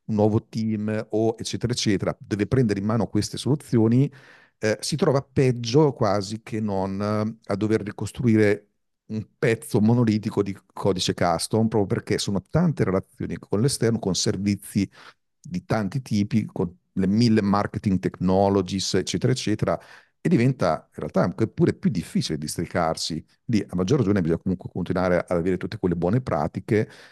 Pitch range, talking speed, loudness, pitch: 95-115 Hz, 155 wpm, -24 LUFS, 105 Hz